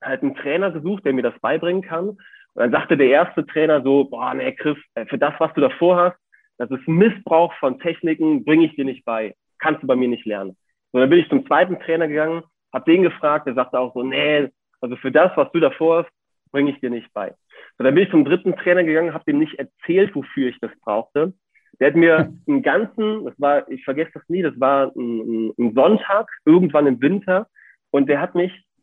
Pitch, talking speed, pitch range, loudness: 160 Hz, 225 wpm, 135-180 Hz, -19 LUFS